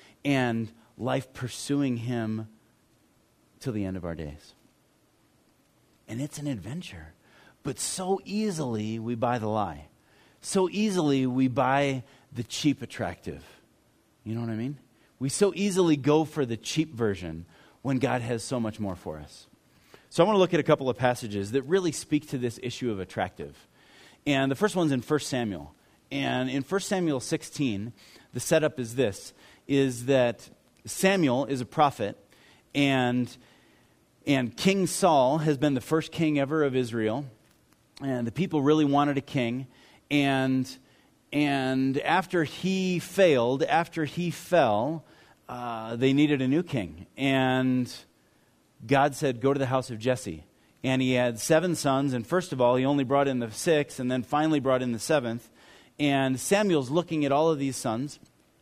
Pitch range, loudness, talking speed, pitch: 120-150 Hz, -27 LUFS, 165 wpm, 135 Hz